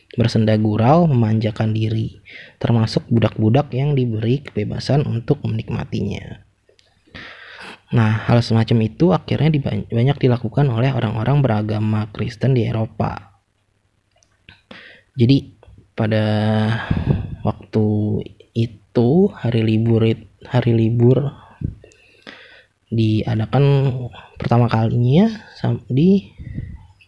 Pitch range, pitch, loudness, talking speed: 110-125 Hz, 115 Hz, -18 LUFS, 80 wpm